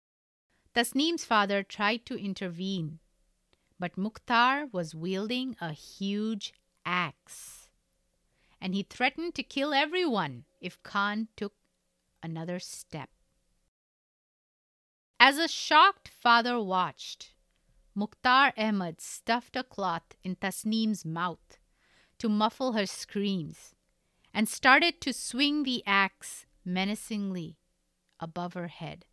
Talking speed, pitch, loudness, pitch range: 105 wpm, 205 Hz, -28 LUFS, 180-245 Hz